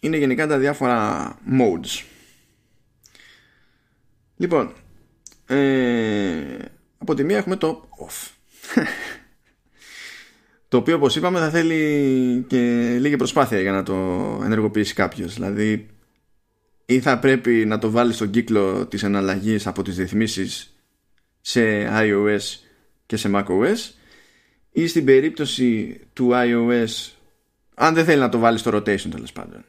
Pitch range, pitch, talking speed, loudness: 105-135 Hz, 115 Hz, 125 wpm, -20 LUFS